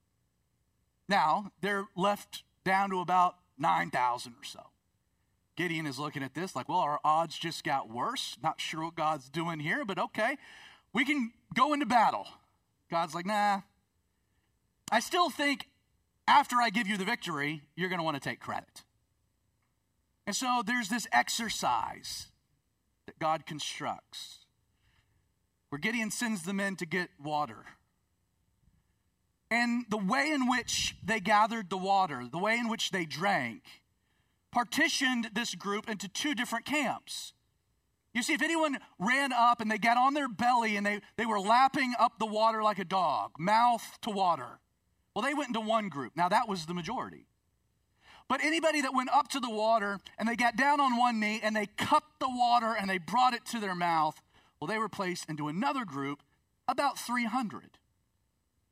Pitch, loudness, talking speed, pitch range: 205 Hz, -31 LUFS, 170 wpm, 160-240 Hz